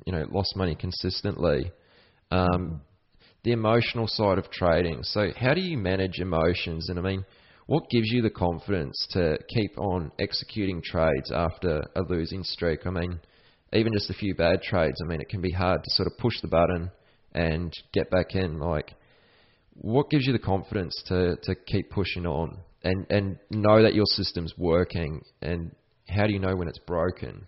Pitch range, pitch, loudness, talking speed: 85-105 Hz, 95 Hz, -27 LUFS, 185 wpm